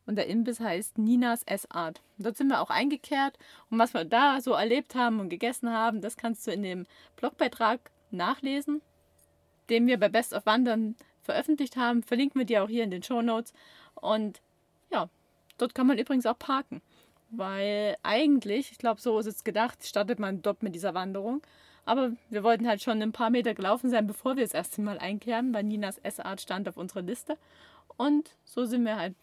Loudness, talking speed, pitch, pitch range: -29 LUFS, 195 wpm, 230 Hz, 210-255 Hz